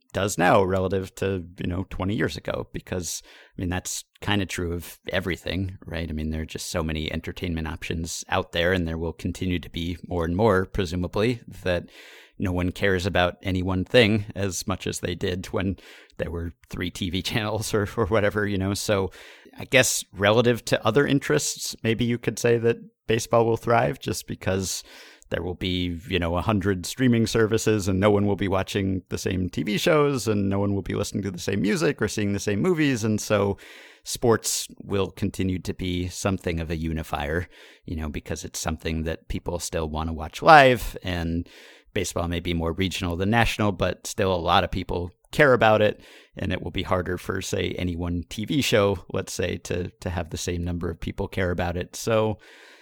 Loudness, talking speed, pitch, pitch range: -25 LUFS, 210 wpm, 95 Hz, 90-105 Hz